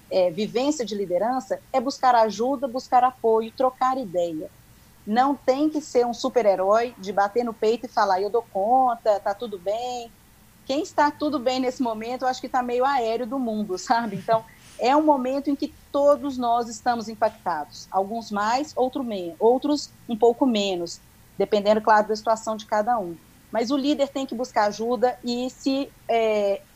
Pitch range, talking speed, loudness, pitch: 215-260 Hz, 180 wpm, -24 LUFS, 240 Hz